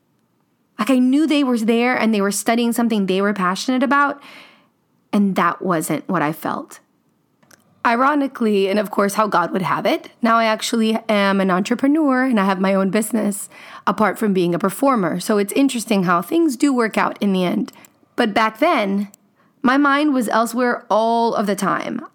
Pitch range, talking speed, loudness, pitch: 200-255 Hz, 185 wpm, -18 LUFS, 220 Hz